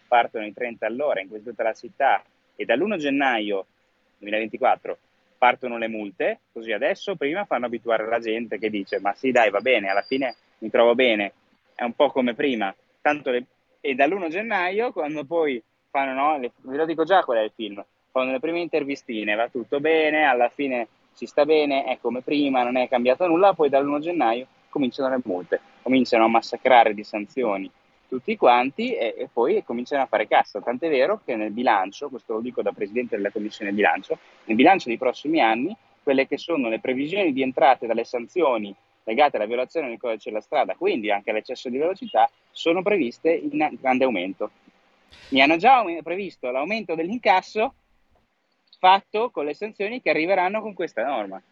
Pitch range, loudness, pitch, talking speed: 115-160 Hz, -23 LUFS, 130 Hz, 180 wpm